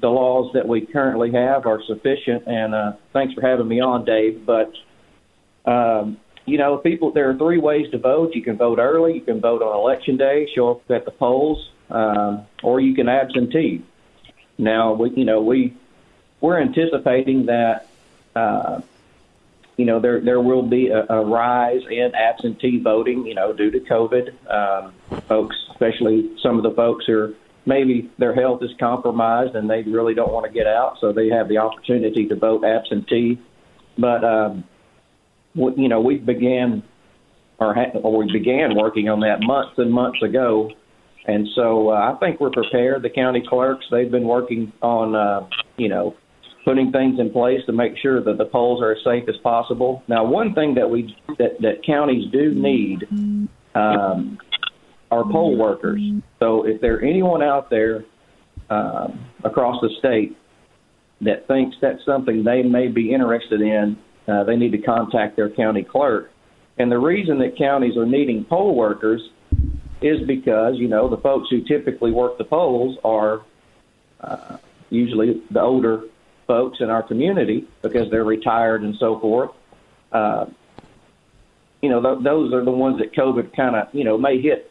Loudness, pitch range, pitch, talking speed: -19 LUFS, 110-130 Hz, 120 Hz, 175 wpm